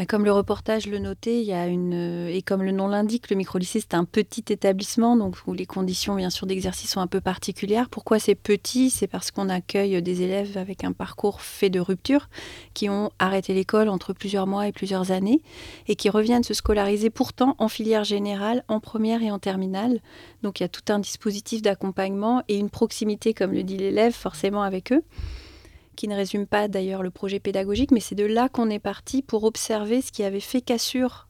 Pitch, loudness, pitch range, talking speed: 205 Hz, -24 LUFS, 190-220 Hz, 210 wpm